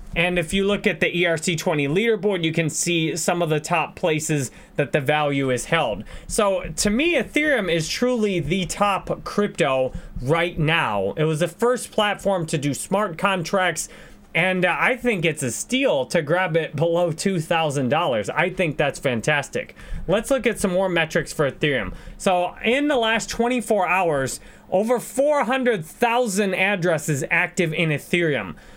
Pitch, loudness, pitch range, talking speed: 180 Hz, -21 LUFS, 165-205 Hz, 160 wpm